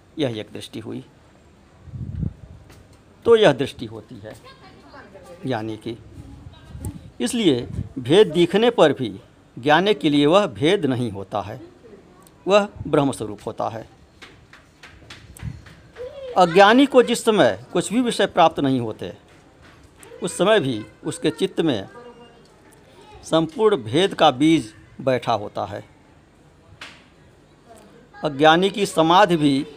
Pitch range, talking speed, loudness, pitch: 130-210 Hz, 110 wpm, -19 LUFS, 160 Hz